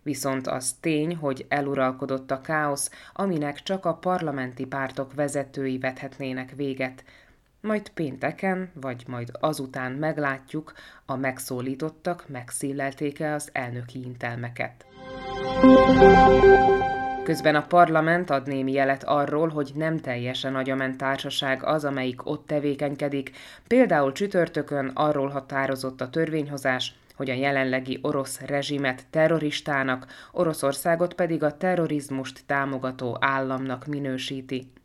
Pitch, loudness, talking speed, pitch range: 140 Hz, -25 LUFS, 105 wpm, 130-150 Hz